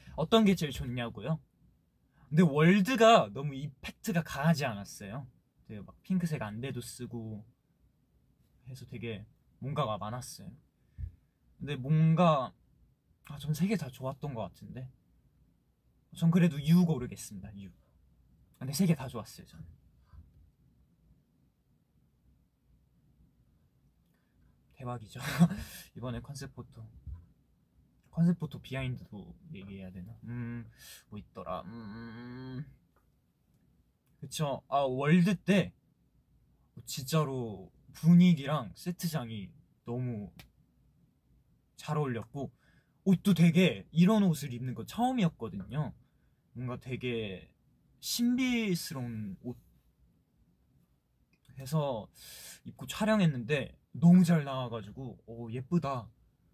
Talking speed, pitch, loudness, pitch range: 205 characters per minute, 135 Hz, -31 LUFS, 115-165 Hz